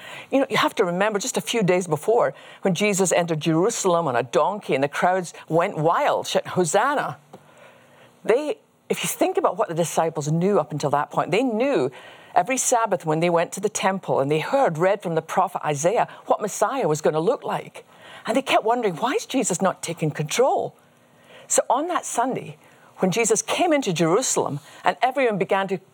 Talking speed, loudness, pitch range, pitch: 200 wpm, -22 LUFS, 165-225 Hz, 190 Hz